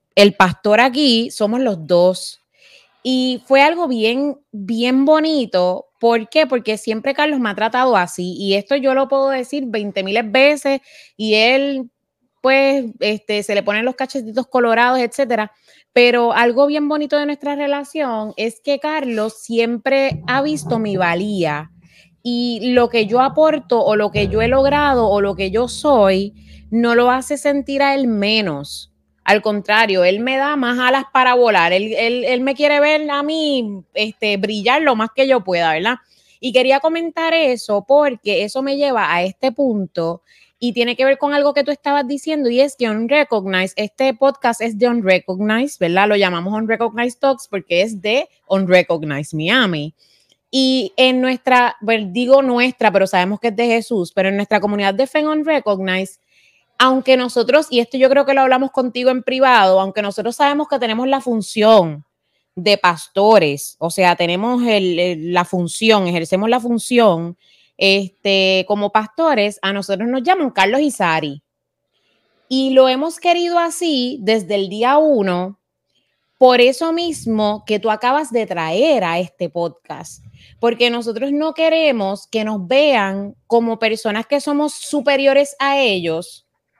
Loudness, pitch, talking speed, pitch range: -16 LUFS, 235 Hz, 170 wpm, 200-270 Hz